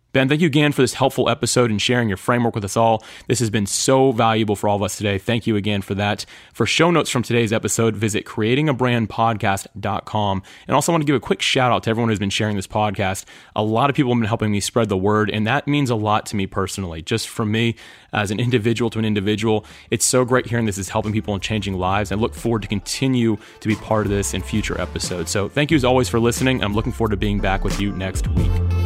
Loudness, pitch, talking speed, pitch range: -20 LUFS, 110 Hz, 260 wpm, 100-120 Hz